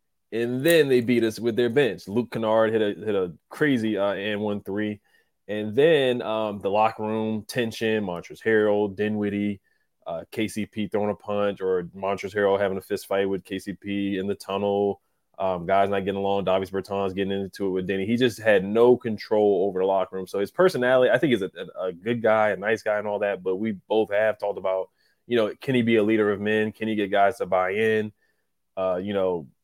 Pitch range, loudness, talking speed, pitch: 100-110 Hz, -24 LUFS, 220 wpm, 105 Hz